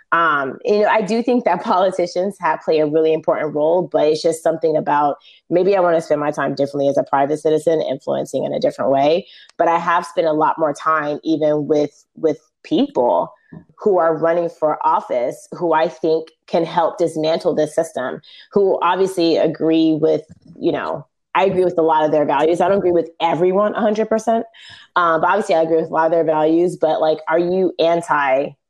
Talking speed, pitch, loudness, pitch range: 205 wpm, 165 Hz, -17 LUFS, 155-180 Hz